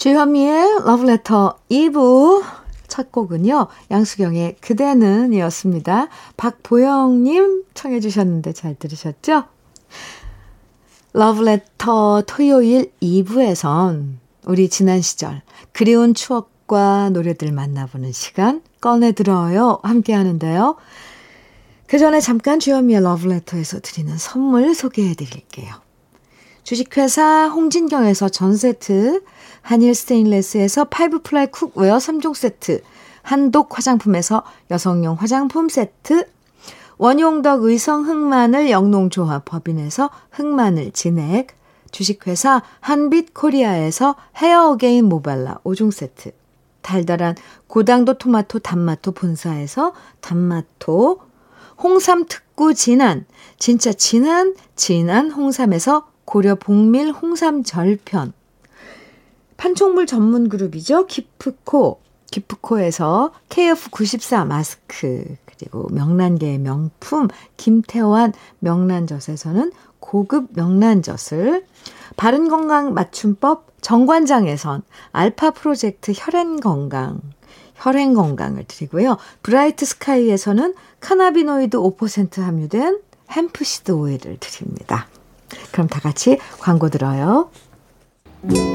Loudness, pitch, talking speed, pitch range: -16 LUFS, 230 Hz, 245 characters per minute, 180-280 Hz